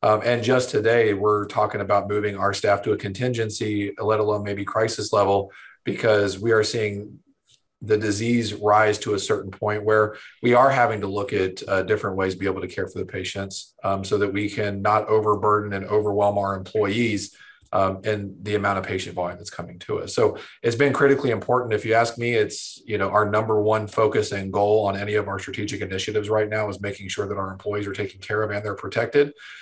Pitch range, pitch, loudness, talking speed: 100-110 Hz, 105 Hz, -23 LUFS, 220 wpm